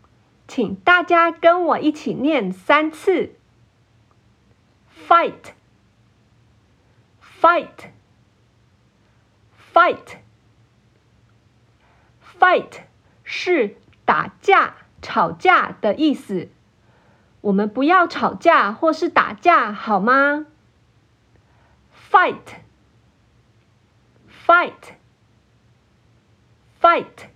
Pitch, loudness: 120 Hz, -17 LUFS